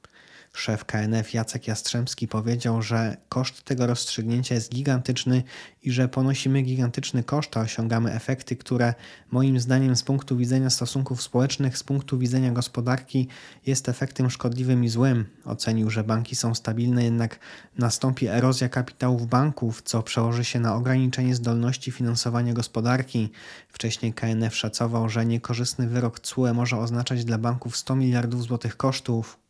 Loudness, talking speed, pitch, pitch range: -25 LUFS, 140 wpm, 120 Hz, 115-130 Hz